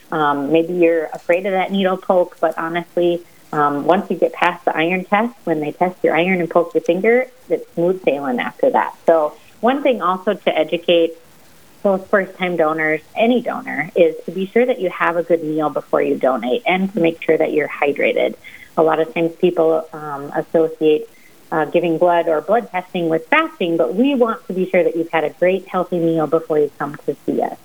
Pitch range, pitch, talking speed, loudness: 160-185 Hz, 170 Hz, 210 wpm, -18 LUFS